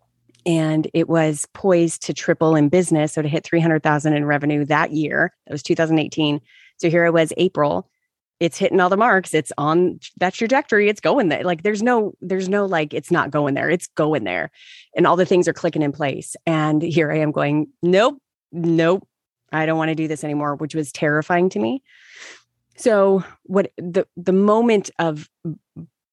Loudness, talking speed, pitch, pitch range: -19 LUFS, 200 wpm, 165 Hz, 155-185 Hz